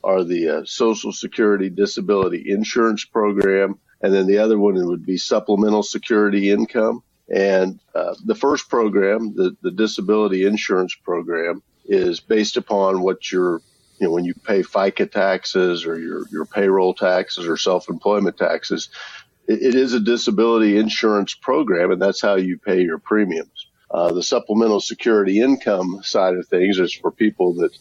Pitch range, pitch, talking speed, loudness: 95-110 Hz, 100 Hz, 160 wpm, -19 LUFS